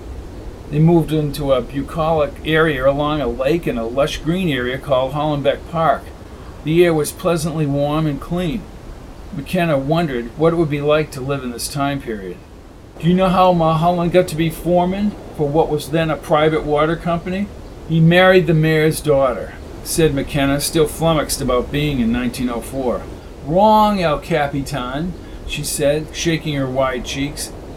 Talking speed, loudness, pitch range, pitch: 165 wpm, -17 LUFS, 135-165 Hz, 150 Hz